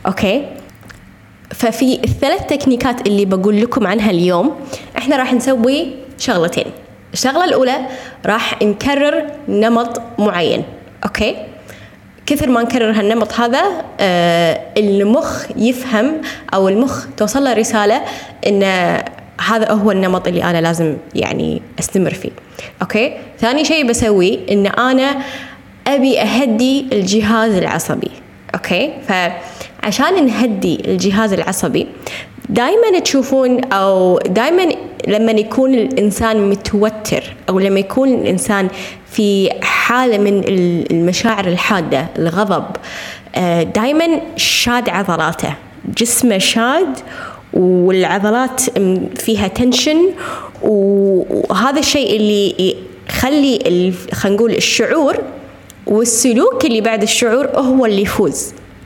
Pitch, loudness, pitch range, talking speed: 225 Hz, -14 LUFS, 200-265 Hz, 100 wpm